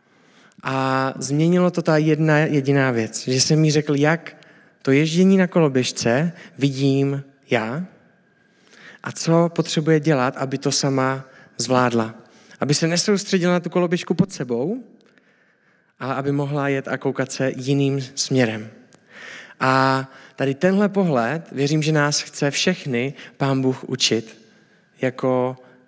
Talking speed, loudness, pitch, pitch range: 130 wpm, -20 LUFS, 140 Hz, 130-165 Hz